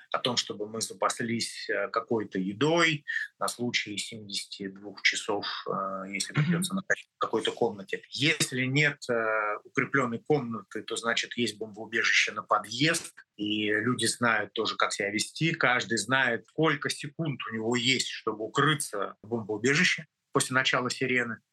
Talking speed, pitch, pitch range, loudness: 135 wpm, 120 Hz, 110-150 Hz, -28 LUFS